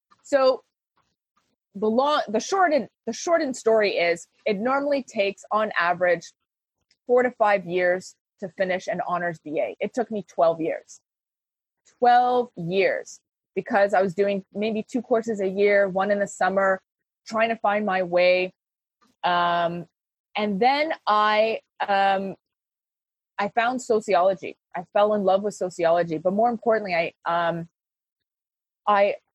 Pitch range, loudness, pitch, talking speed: 180-225 Hz, -23 LUFS, 200 Hz, 140 wpm